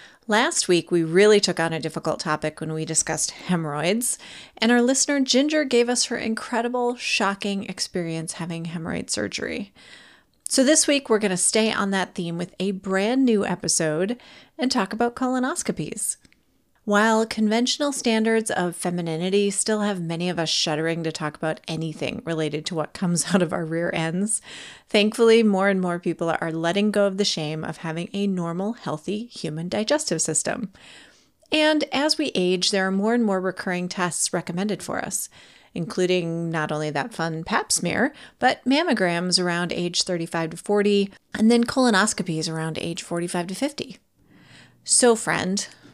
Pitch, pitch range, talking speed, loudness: 190 Hz, 170-225 Hz, 165 wpm, -23 LUFS